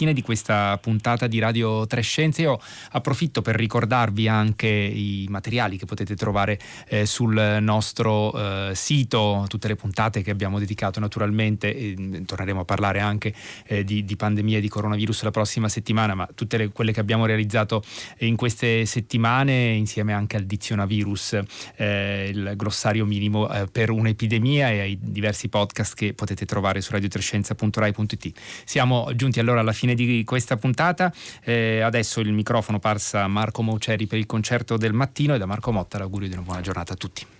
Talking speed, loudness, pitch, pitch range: 170 wpm, -23 LUFS, 110 Hz, 105-115 Hz